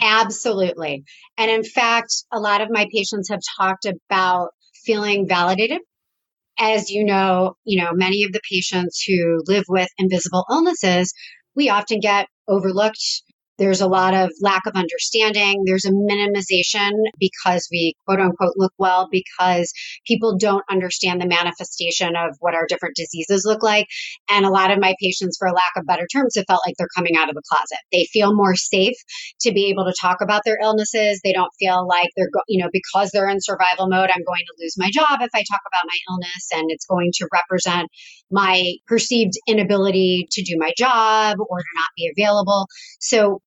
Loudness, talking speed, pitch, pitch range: -18 LUFS, 185 wpm, 190 Hz, 180-210 Hz